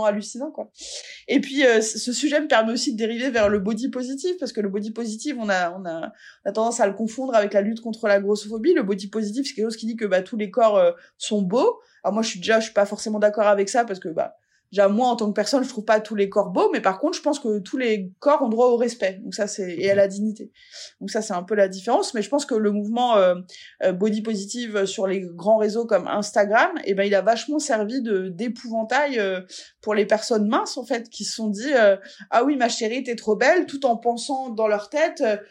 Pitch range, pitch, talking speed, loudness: 205-265 Hz, 225 Hz, 265 wpm, -22 LUFS